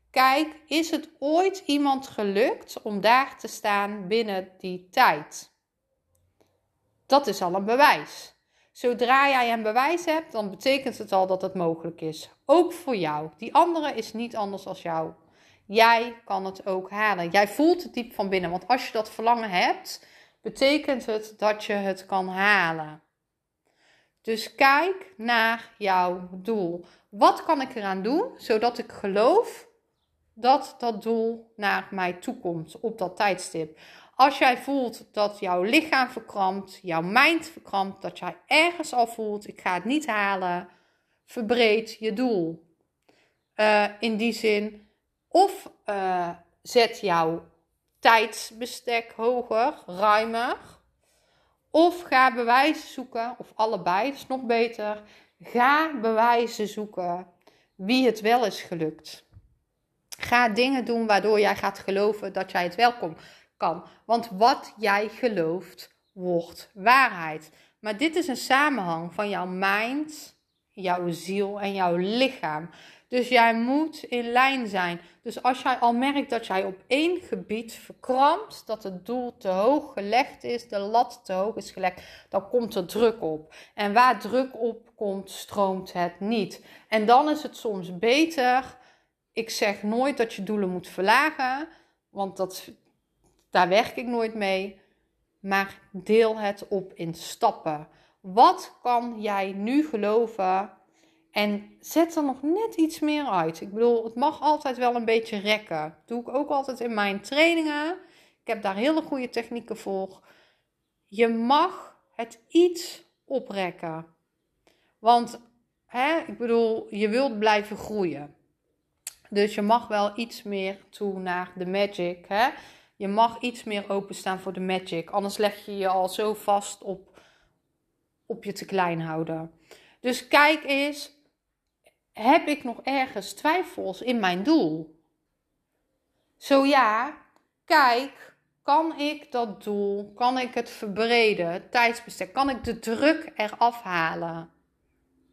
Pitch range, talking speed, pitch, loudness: 190-255 Hz, 145 wpm, 220 Hz, -25 LUFS